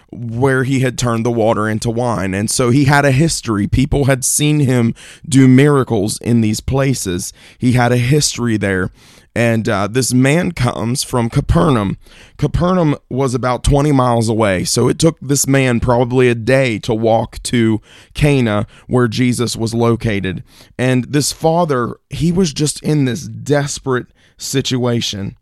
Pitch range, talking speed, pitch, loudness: 115-135 Hz, 160 wpm, 125 Hz, -15 LUFS